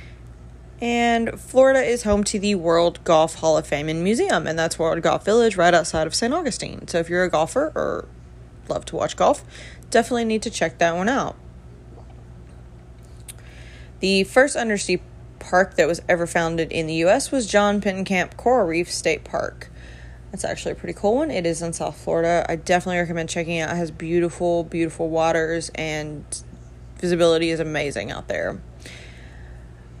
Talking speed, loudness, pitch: 170 wpm, -21 LUFS, 165 Hz